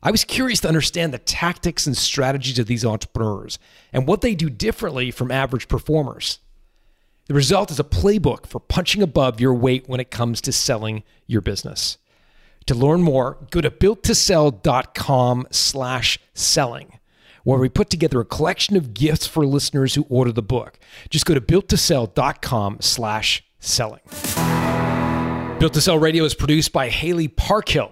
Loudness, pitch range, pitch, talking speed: -19 LUFS, 120-160 Hz, 135 Hz, 160 wpm